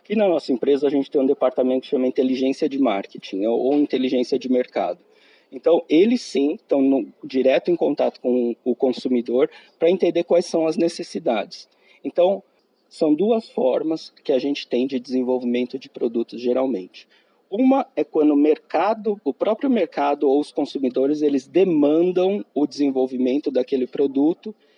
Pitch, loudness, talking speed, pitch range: 140 Hz, -21 LUFS, 155 wpm, 130-170 Hz